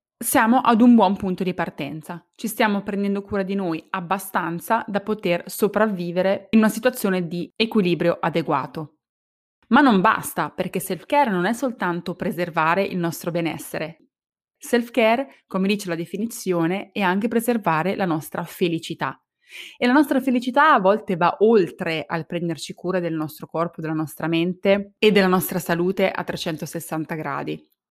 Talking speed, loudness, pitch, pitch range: 150 wpm, -22 LUFS, 185 Hz, 170-210 Hz